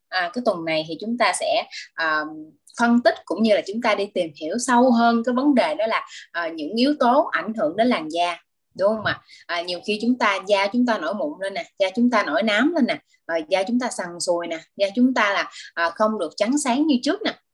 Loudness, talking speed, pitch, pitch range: -22 LUFS, 265 wpm, 235 Hz, 185-295 Hz